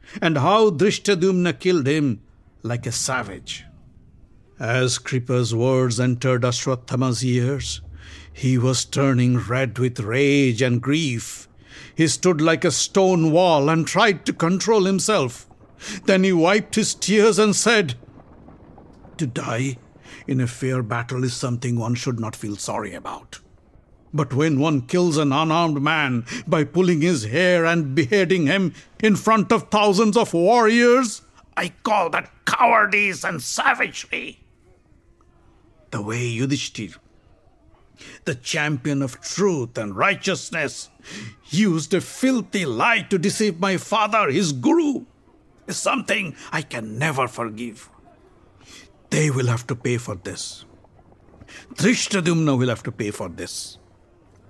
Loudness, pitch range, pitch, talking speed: -20 LUFS, 120-185 Hz, 140 Hz, 130 wpm